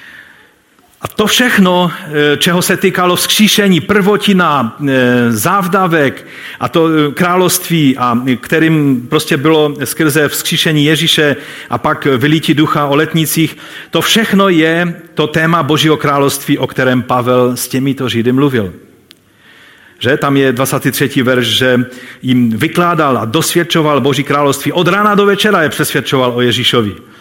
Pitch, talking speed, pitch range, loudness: 150 Hz, 130 wpm, 130-170 Hz, -11 LUFS